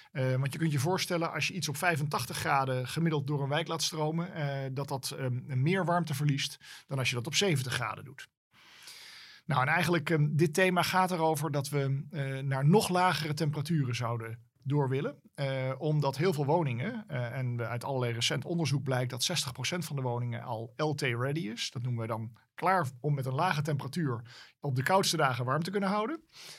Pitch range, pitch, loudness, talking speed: 130-165 Hz, 145 Hz, -31 LUFS, 200 wpm